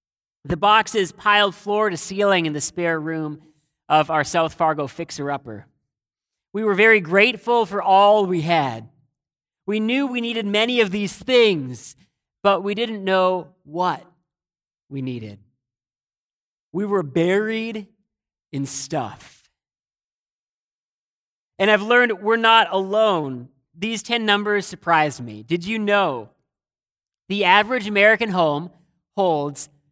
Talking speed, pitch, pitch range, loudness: 125 wpm, 185 Hz, 150-210 Hz, -19 LUFS